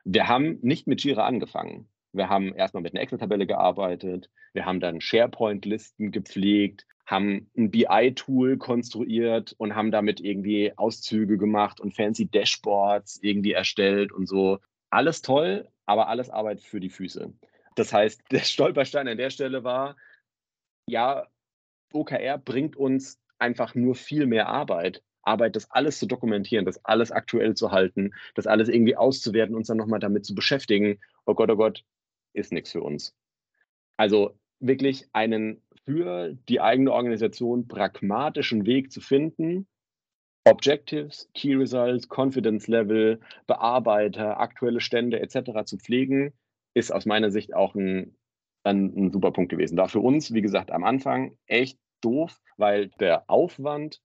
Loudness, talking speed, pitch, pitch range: -25 LUFS, 150 wpm, 110 Hz, 100-130 Hz